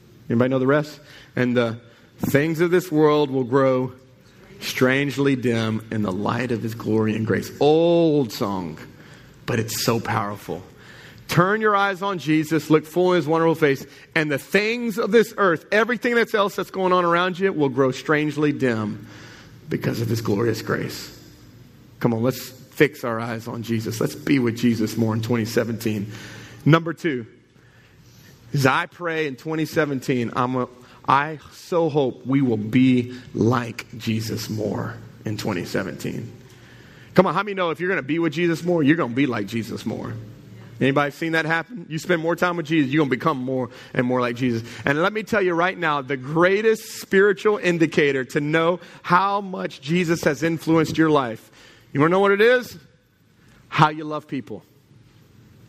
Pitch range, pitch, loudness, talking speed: 120-165 Hz, 140 Hz, -21 LUFS, 180 wpm